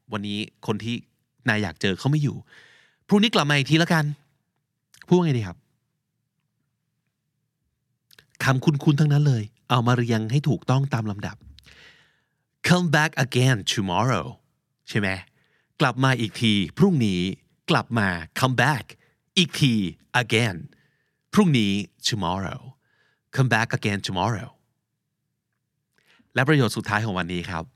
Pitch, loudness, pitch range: 130 Hz, -23 LUFS, 110-150 Hz